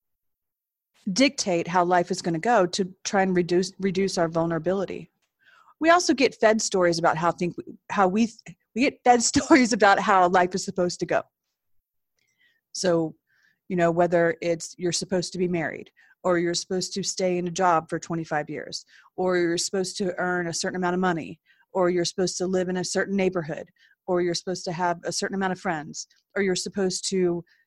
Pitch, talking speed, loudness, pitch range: 185 Hz, 195 wpm, -24 LUFS, 175-200 Hz